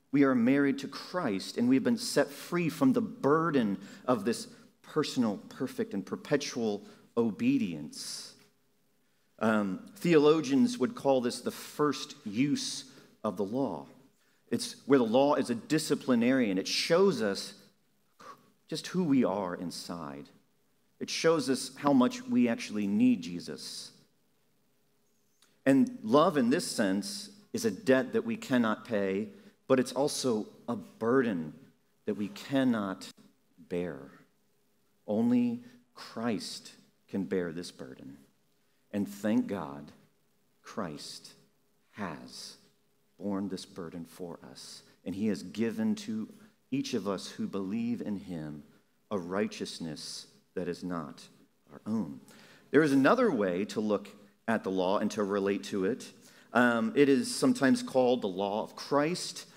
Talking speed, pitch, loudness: 135 wpm, 145 Hz, -31 LUFS